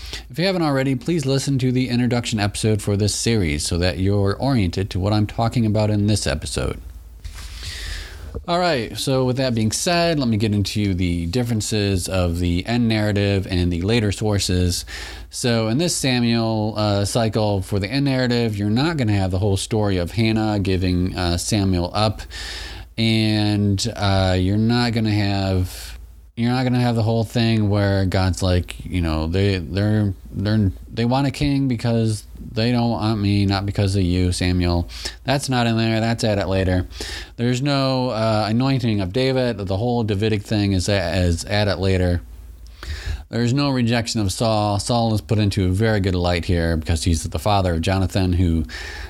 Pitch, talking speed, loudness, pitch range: 105 Hz, 185 wpm, -20 LUFS, 90-115 Hz